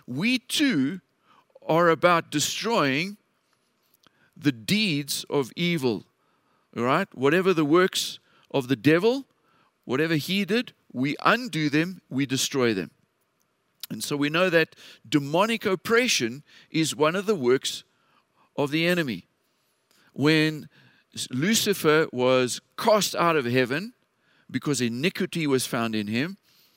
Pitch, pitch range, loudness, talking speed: 160 Hz, 140-190 Hz, -24 LUFS, 120 wpm